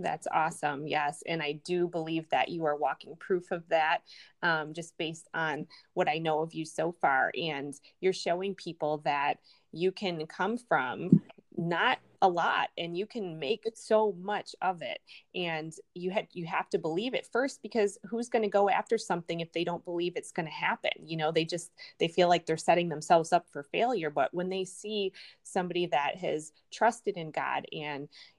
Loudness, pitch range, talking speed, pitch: -31 LUFS, 160-190 Hz, 195 wpm, 175 Hz